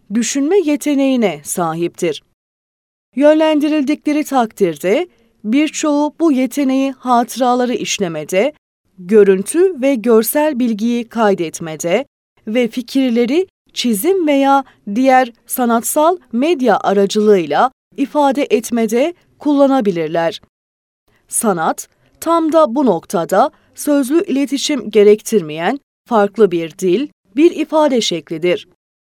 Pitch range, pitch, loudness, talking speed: 200-290 Hz, 245 Hz, -15 LUFS, 85 wpm